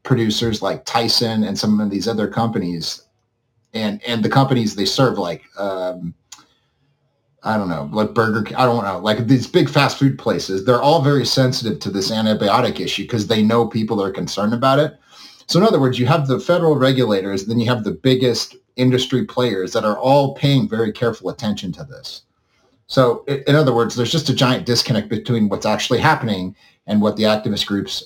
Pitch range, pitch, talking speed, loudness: 105-130 Hz, 115 Hz, 190 wpm, -18 LUFS